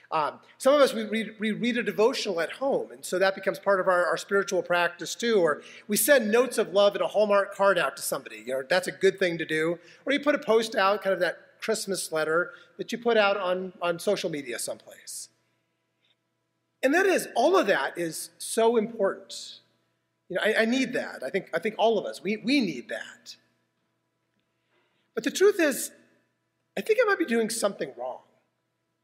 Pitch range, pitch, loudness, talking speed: 180-230 Hz, 200 Hz, -26 LUFS, 210 wpm